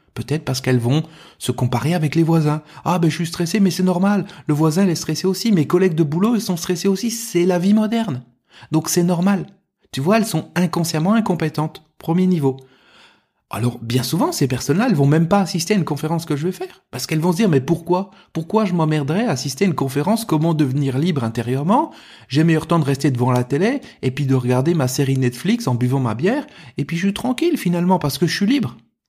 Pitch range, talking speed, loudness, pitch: 140-190 Hz, 225 wpm, -19 LUFS, 165 Hz